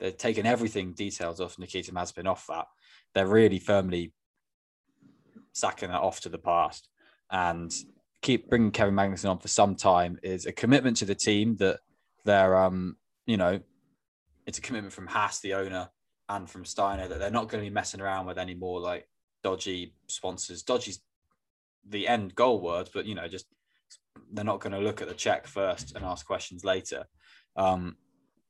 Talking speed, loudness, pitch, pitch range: 180 wpm, -29 LUFS, 95 Hz, 90-100 Hz